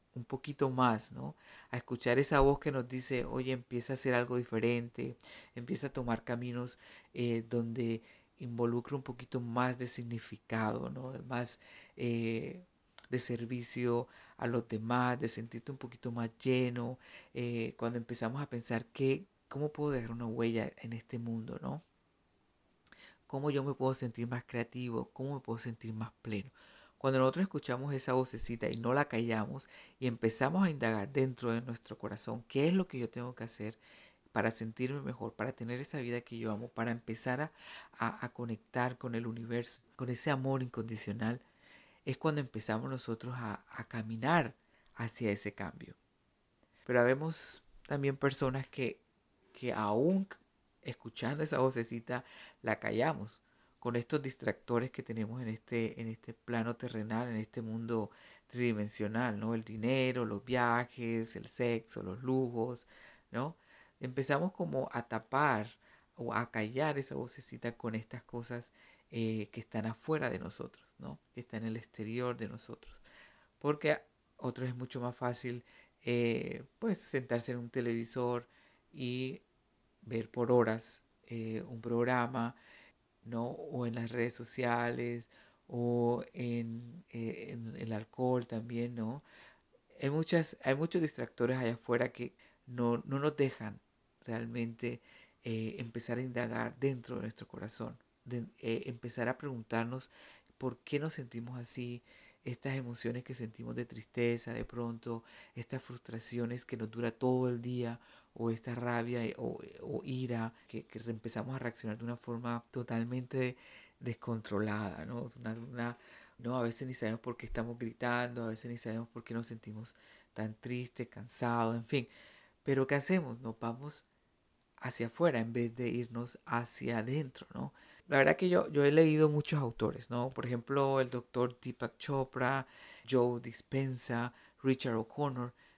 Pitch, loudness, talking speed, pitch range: 120 Hz, -37 LUFS, 155 wpm, 115-130 Hz